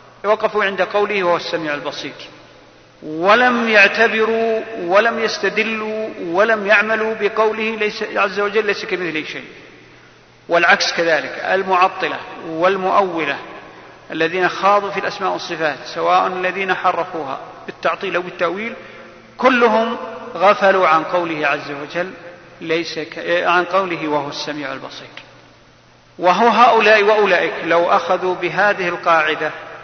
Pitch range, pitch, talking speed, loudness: 165-215 Hz, 185 Hz, 110 wpm, -16 LUFS